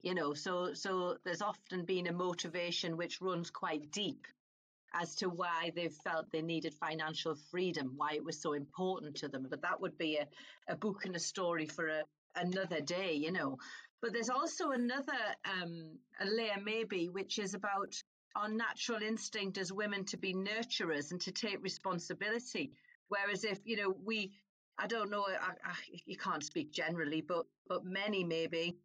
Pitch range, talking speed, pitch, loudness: 165-205 Hz, 180 wpm, 185 Hz, -39 LUFS